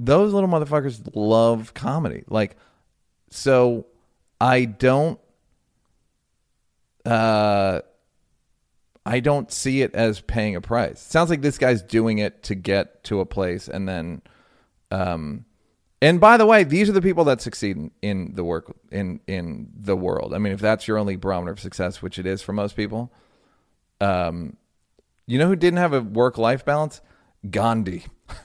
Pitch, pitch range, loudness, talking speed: 110 Hz, 95-130 Hz, -21 LUFS, 160 wpm